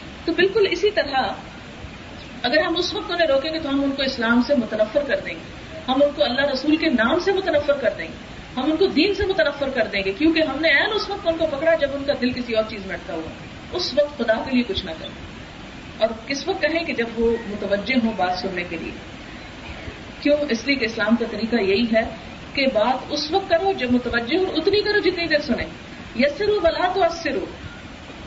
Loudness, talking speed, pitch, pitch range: -21 LUFS, 230 wpm, 285 Hz, 235-330 Hz